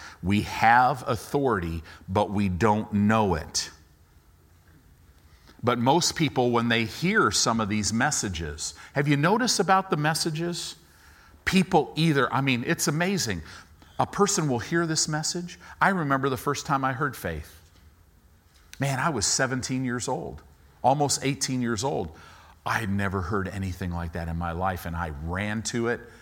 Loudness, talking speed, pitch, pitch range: -25 LUFS, 160 wpm, 110 Hz, 85-140 Hz